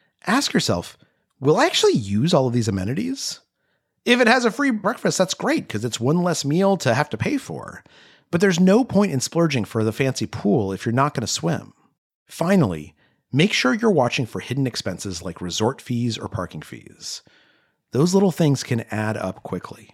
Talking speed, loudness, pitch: 195 wpm, -21 LUFS, 135 Hz